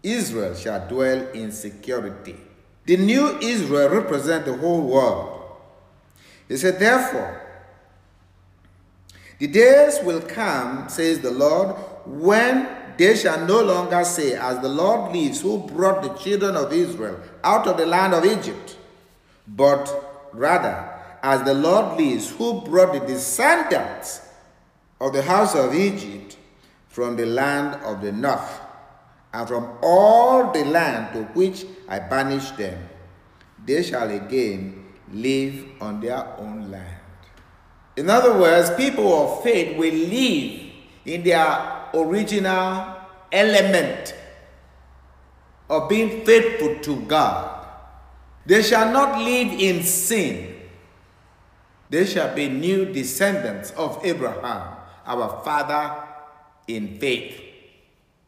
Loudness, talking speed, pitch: -20 LUFS, 120 wpm, 150 Hz